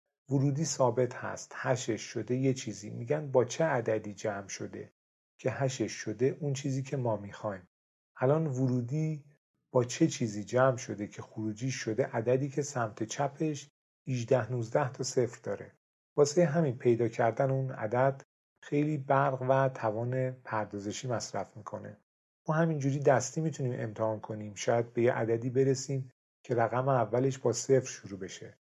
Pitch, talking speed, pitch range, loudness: 125 Hz, 150 wpm, 110-135 Hz, -31 LUFS